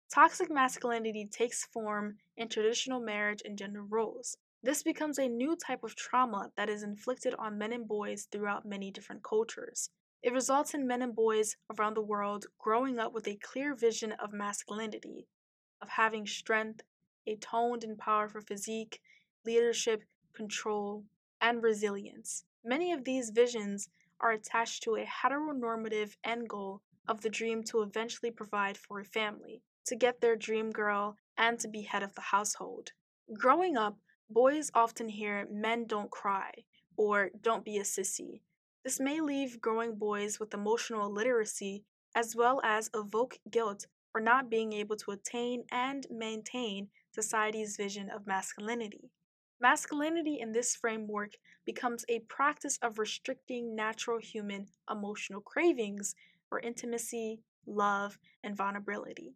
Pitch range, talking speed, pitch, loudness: 210-240 Hz, 145 wpm, 220 Hz, -34 LUFS